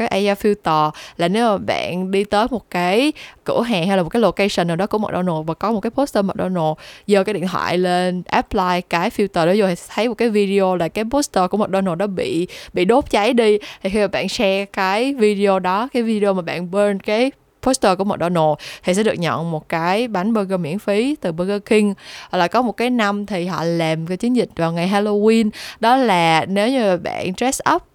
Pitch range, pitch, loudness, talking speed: 180-220 Hz, 200 Hz, -18 LUFS, 230 wpm